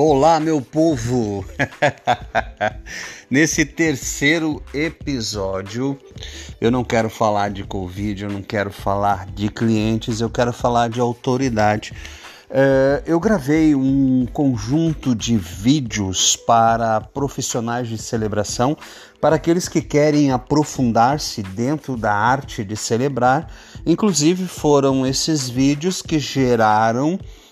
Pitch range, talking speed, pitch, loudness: 110-150 Hz, 110 wpm, 125 Hz, -19 LUFS